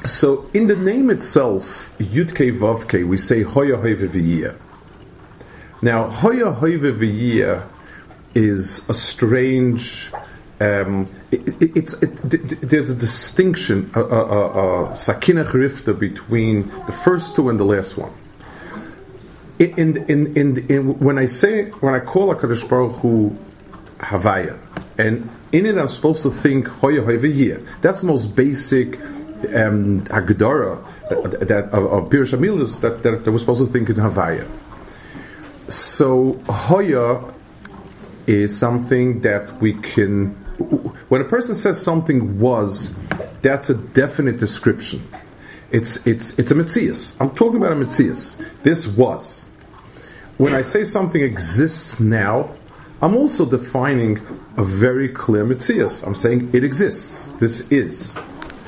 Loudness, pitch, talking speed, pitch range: -18 LUFS, 125 Hz, 125 wpm, 110-150 Hz